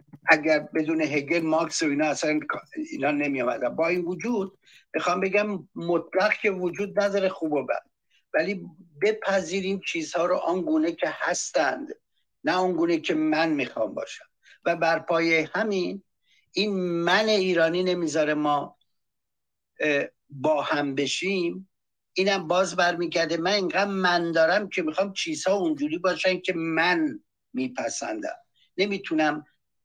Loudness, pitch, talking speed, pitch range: -25 LUFS, 180 Hz, 130 wpm, 160-195 Hz